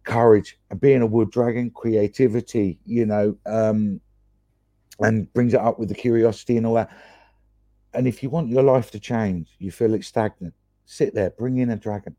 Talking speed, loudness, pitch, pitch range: 185 wpm, -21 LUFS, 110 Hz, 105-120 Hz